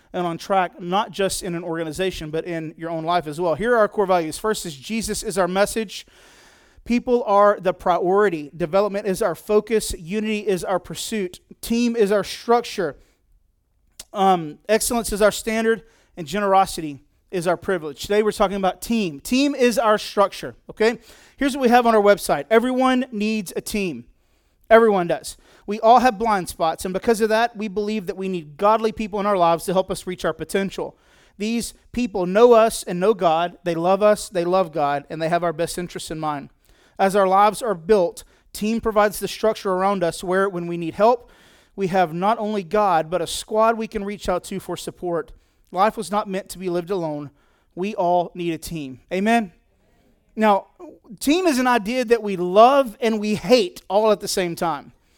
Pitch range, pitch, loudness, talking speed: 175-220 Hz, 200 Hz, -21 LUFS, 200 wpm